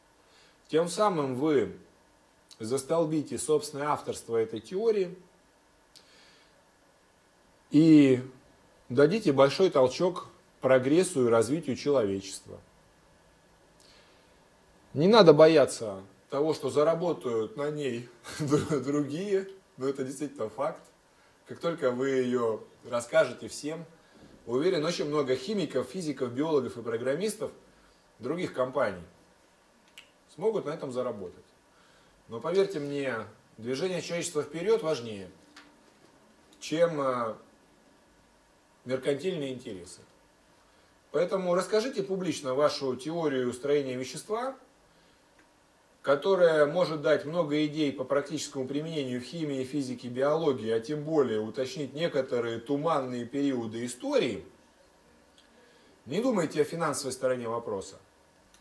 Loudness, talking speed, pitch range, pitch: -28 LUFS, 95 wpm, 130-160 Hz, 145 Hz